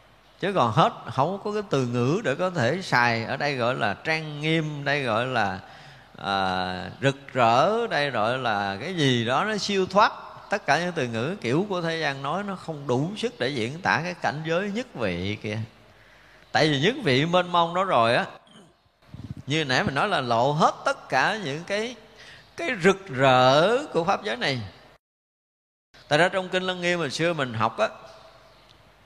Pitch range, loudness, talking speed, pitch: 120-180 Hz, -24 LUFS, 195 wpm, 145 Hz